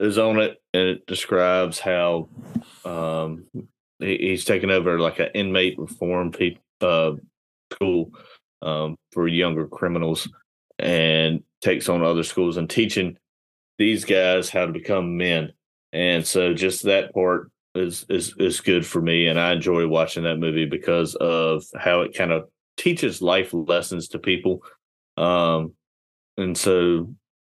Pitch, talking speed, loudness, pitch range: 85 Hz, 145 wpm, -22 LUFS, 80-90 Hz